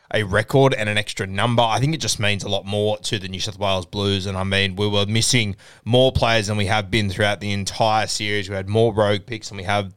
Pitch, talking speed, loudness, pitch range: 105 Hz, 265 wpm, -20 LUFS, 100-115 Hz